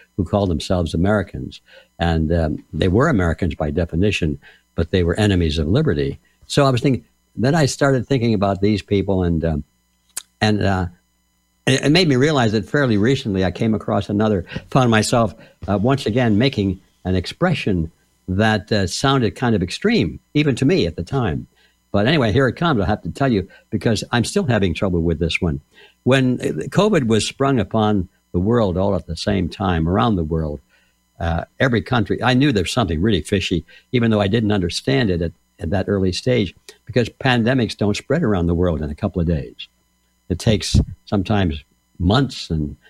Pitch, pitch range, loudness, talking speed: 100 Hz, 85-120 Hz, -19 LUFS, 185 wpm